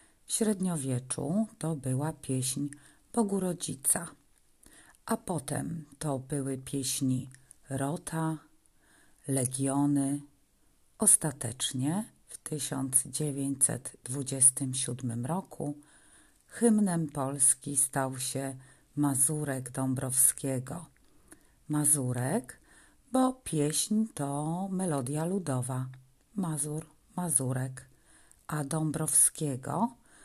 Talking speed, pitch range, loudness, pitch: 65 wpm, 135-160 Hz, -30 LUFS, 145 Hz